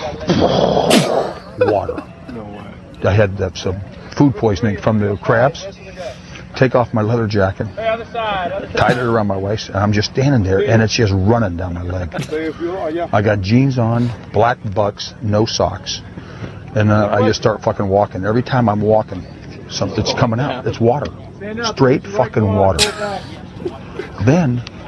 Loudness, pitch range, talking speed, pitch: -16 LUFS, 100-120 Hz, 140 wpm, 110 Hz